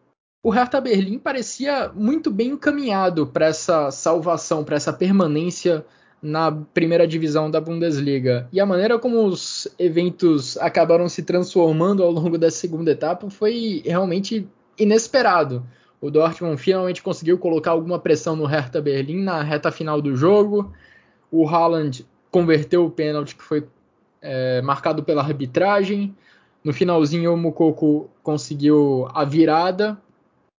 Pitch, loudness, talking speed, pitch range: 170 Hz, -20 LUFS, 135 wpm, 155-190 Hz